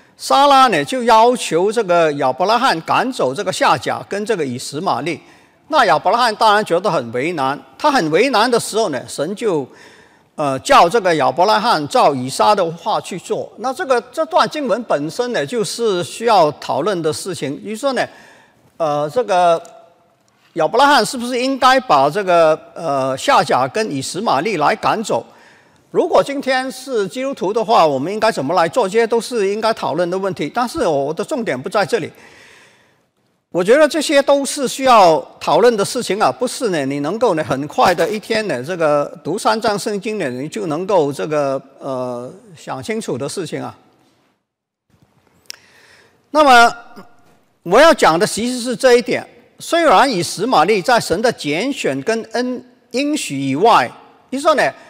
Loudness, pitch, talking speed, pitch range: -16 LUFS, 220 Hz, 250 characters per minute, 165-255 Hz